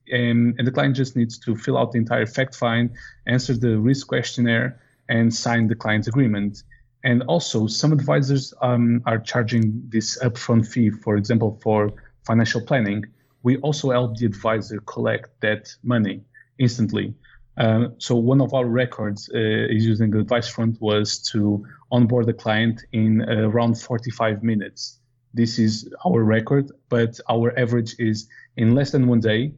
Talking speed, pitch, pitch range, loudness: 165 wpm, 115 Hz, 110-125 Hz, -21 LUFS